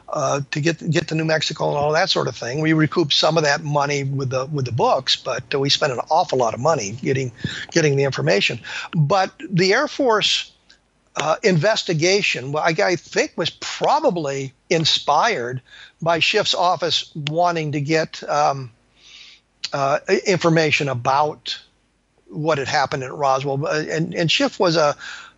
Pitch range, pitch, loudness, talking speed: 140-170 Hz, 155 Hz, -19 LUFS, 160 wpm